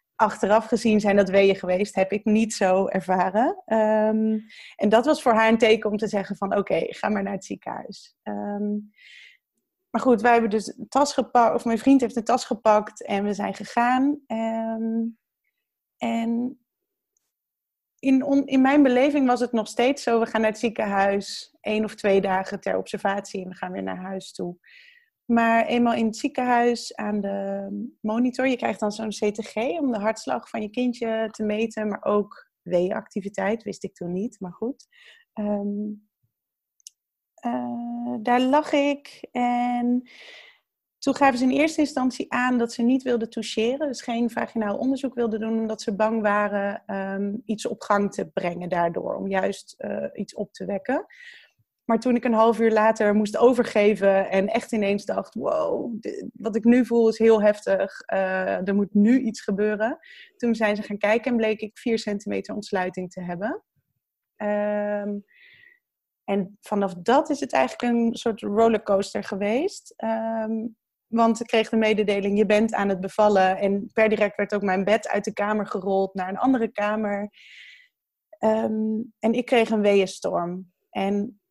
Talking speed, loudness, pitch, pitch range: 175 wpm, -24 LUFS, 220 Hz, 205-245 Hz